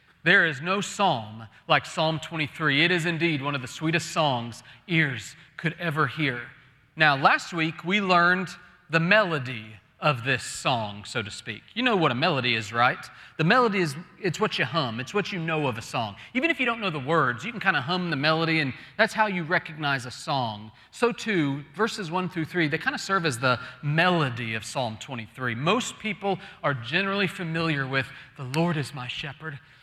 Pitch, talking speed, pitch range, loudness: 160 Hz, 205 wpm, 130-180 Hz, -25 LUFS